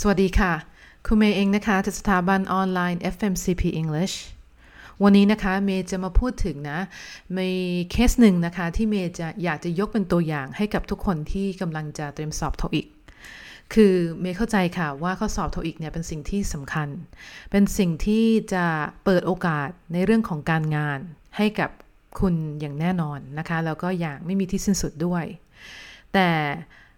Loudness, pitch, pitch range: -24 LUFS, 180 Hz, 160-195 Hz